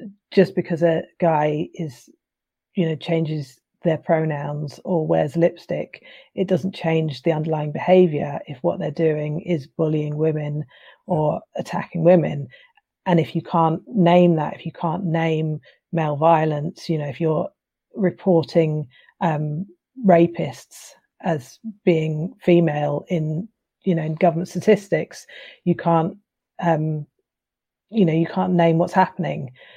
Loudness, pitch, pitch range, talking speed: -21 LUFS, 165 Hz, 155-180 Hz, 135 wpm